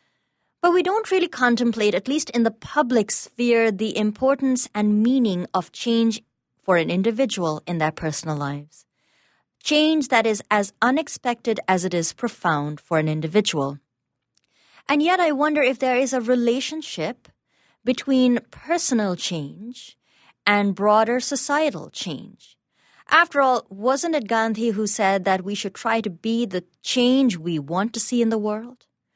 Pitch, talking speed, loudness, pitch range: 225 Hz, 150 wpm, -21 LUFS, 190-260 Hz